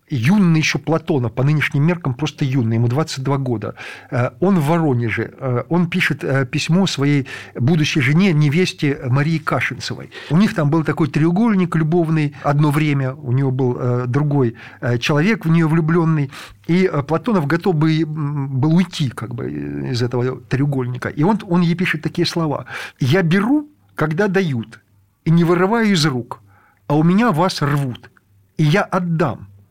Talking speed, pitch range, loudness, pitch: 150 wpm, 130-170 Hz, -18 LUFS, 150 Hz